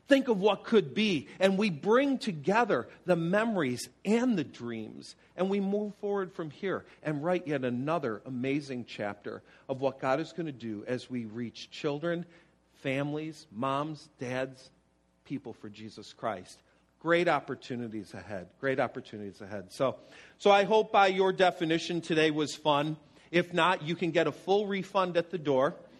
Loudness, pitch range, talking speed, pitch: -30 LUFS, 130-185 Hz, 165 wpm, 155 Hz